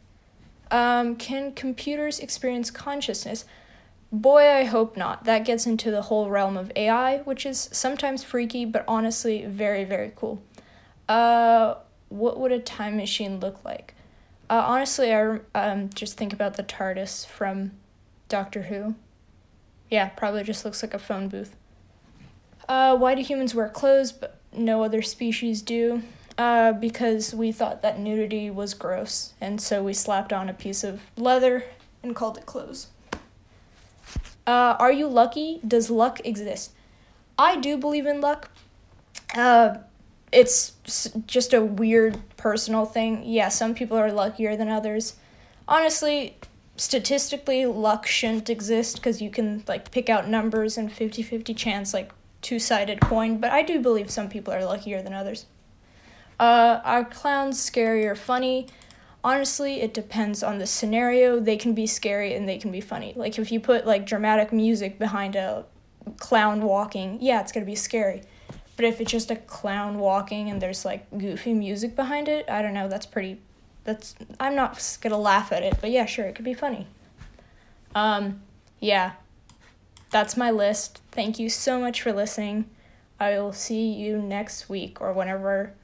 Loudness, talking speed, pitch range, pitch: -24 LUFS, 160 wpm, 205-245 Hz, 225 Hz